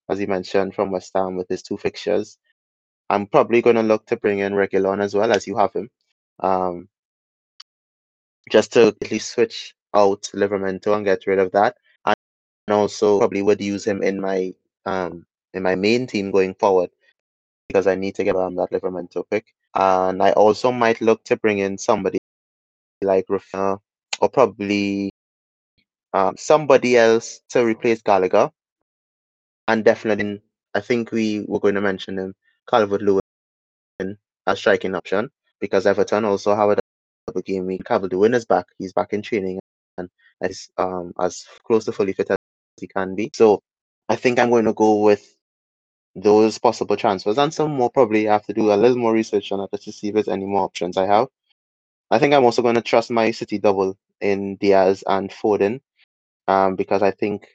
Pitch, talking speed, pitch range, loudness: 100 Hz, 180 wpm, 95-105 Hz, -20 LUFS